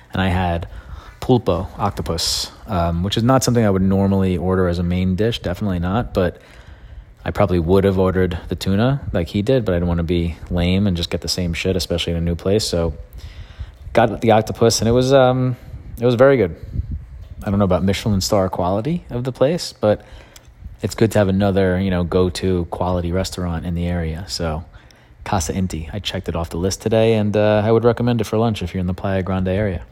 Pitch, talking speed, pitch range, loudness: 95 Hz, 225 wpm, 85-105 Hz, -19 LUFS